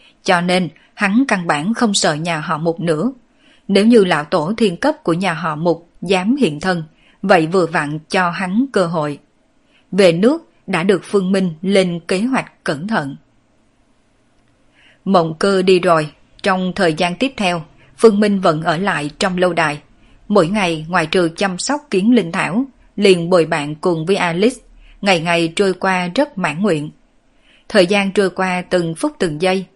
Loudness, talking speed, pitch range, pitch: -16 LUFS, 180 wpm, 170-210 Hz, 185 Hz